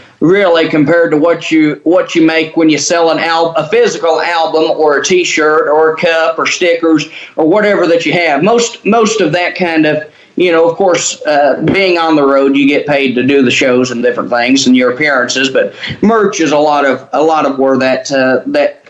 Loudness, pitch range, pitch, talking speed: -10 LUFS, 150-175 Hz, 160 Hz, 220 wpm